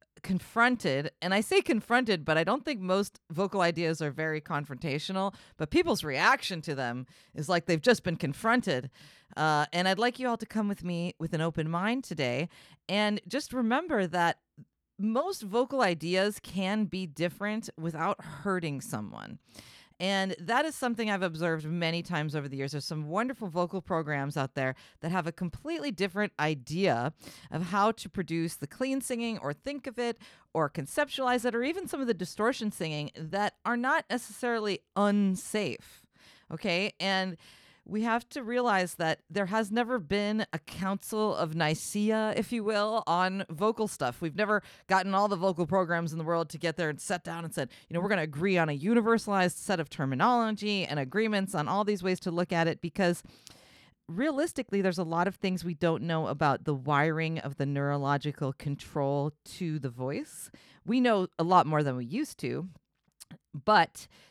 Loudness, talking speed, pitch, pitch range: -30 LUFS, 180 wpm, 185 Hz, 160-215 Hz